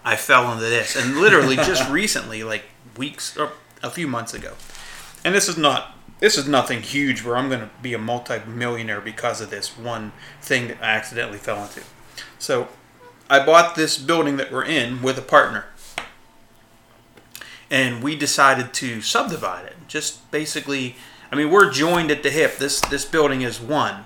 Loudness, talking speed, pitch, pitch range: -20 LUFS, 175 wpm, 130 Hz, 115-145 Hz